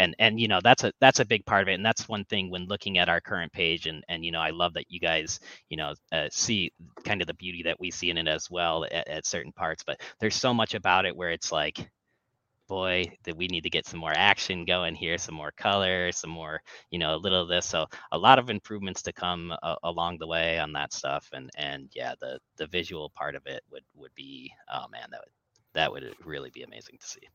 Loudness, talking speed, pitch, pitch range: -27 LUFS, 260 wpm, 90 Hz, 85-105 Hz